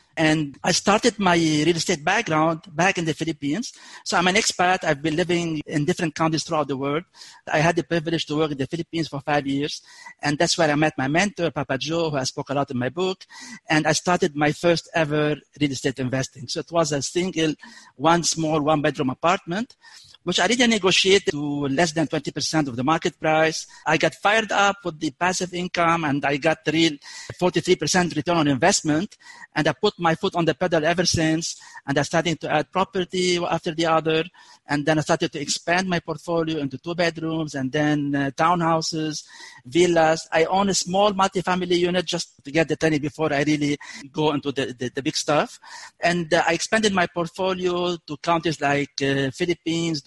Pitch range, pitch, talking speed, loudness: 150-175 Hz, 165 Hz, 200 wpm, -22 LUFS